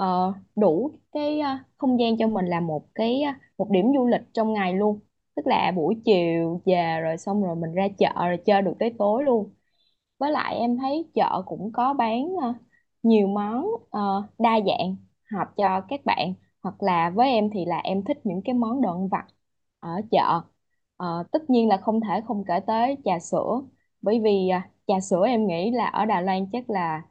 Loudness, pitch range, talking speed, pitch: -24 LUFS, 185-235 Hz, 210 wpm, 205 Hz